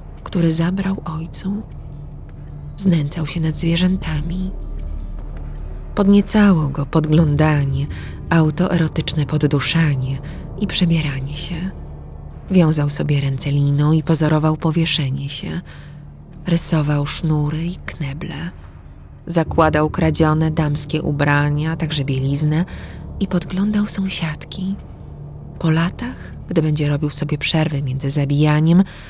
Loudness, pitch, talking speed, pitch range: -17 LUFS, 155 Hz, 95 wpm, 145-165 Hz